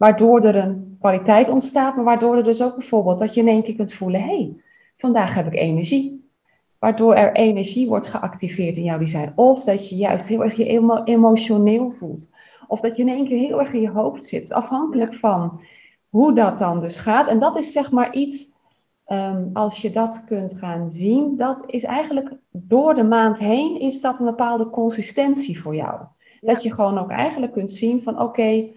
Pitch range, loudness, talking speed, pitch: 200-250 Hz, -19 LUFS, 200 wpm, 225 Hz